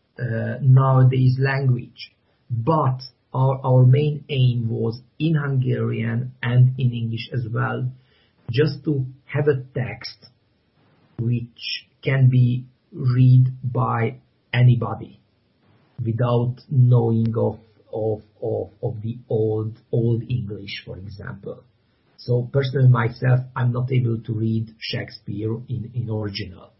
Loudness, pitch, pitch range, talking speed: -21 LUFS, 120 Hz, 115-130 Hz, 115 wpm